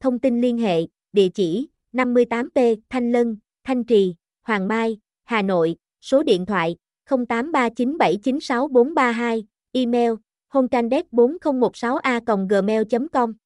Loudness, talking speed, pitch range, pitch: -21 LUFS, 95 wpm, 220-255 Hz, 240 Hz